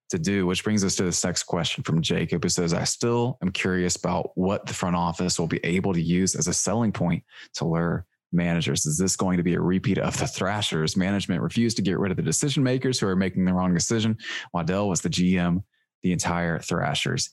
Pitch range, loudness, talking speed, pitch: 85-105 Hz, -24 LUFS, 230 wpm, 90 Hz